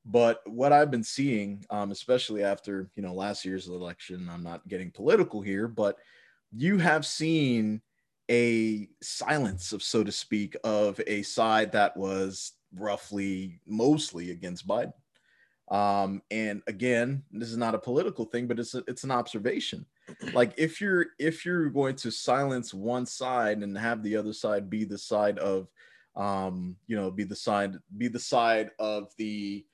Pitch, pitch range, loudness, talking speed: 105 Hz, 100-120 Hz, -29 LUFS, 165 wpm